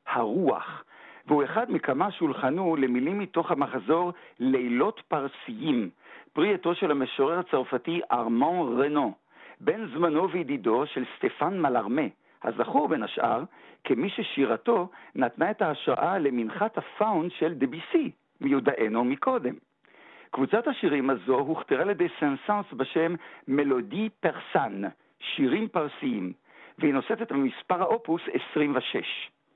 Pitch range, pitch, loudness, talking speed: 135-200 Hz, 165 Hz, -27 LUFS, 115 wpm